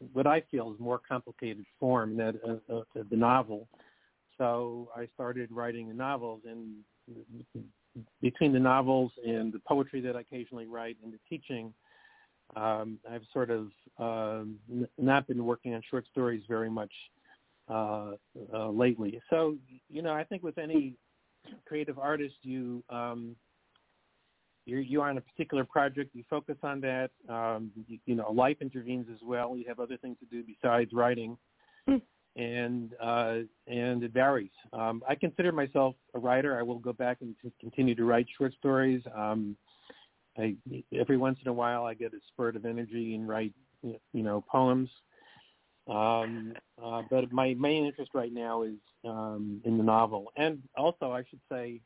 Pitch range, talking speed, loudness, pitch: 115-130 Hz, 170 wpm, -32 LUFS, 120 Hz